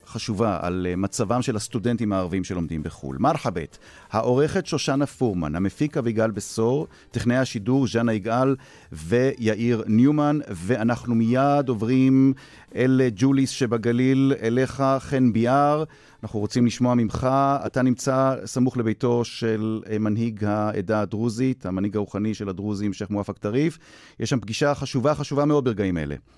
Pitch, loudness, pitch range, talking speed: 120 Hz, -23 LUFS, 105-135 Hz, 130 wpm